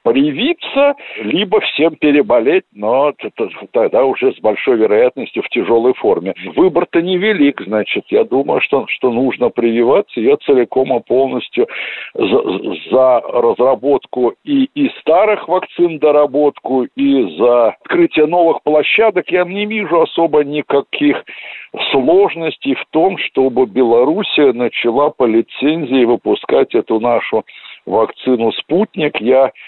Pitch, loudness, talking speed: 180 Hz, -14 LUFS, 115 wpm